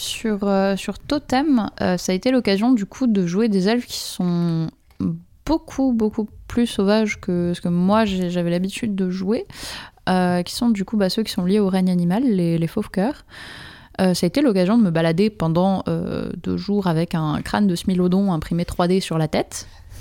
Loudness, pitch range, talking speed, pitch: -20 LUFS, 175-220 Hz, 200 wpm, 190 Hz